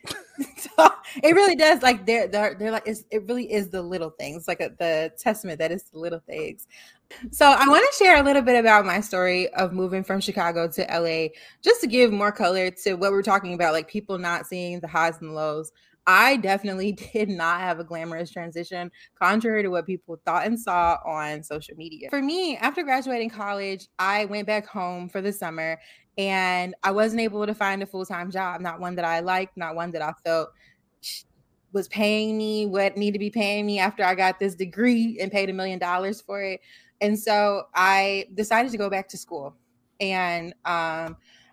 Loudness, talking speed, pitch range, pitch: -23 LUFS, 200 wpm, 170-215 Hz, 195 Hz